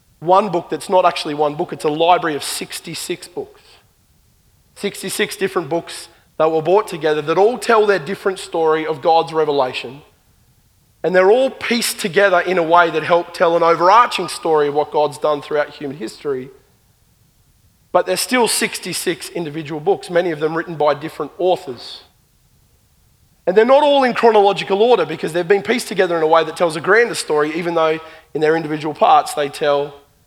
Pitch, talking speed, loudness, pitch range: 170 Hz, 180 wpm, -17 LUFS, 155-200 Hz